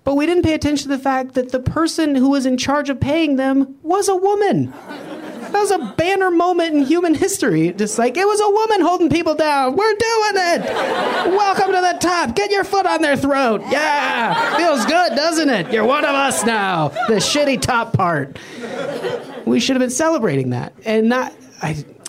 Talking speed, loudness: 200 wpm, -17 LUFS